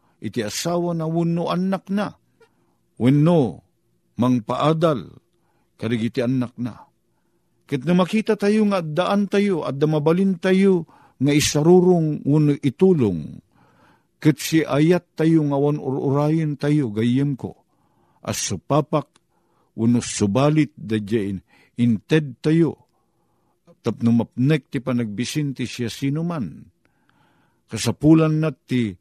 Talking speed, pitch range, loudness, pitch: 110 wpm, 120-170 Hz, -20 LUFS, 150 Hz